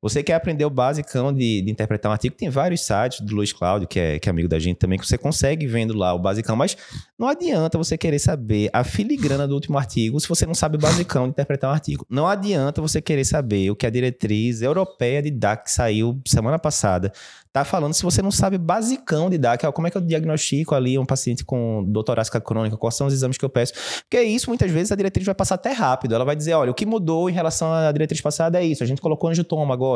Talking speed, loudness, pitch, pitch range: 250 wpm, -21 LUFS, 140 Hz, 115-160 Hz